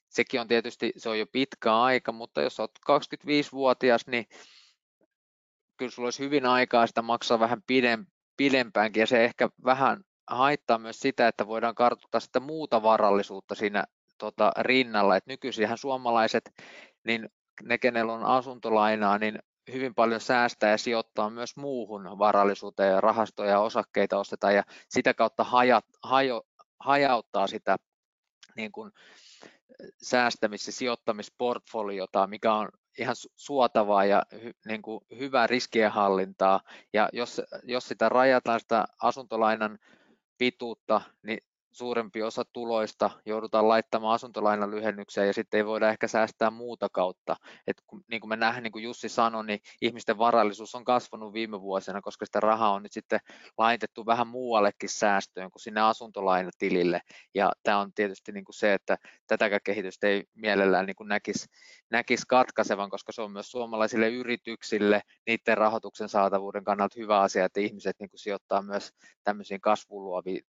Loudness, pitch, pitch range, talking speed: -27 LUFS, 110 Hz, 105-120 Hz, 145 wpm